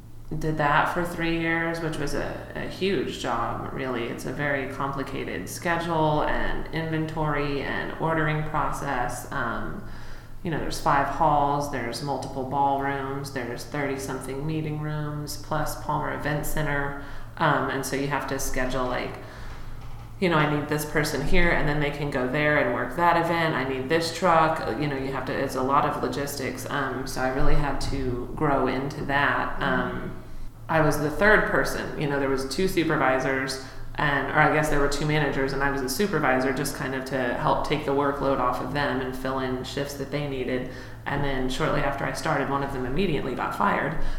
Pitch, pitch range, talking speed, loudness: 140 Hz, 130-150 Hz, 195 wpm, -26 LUFS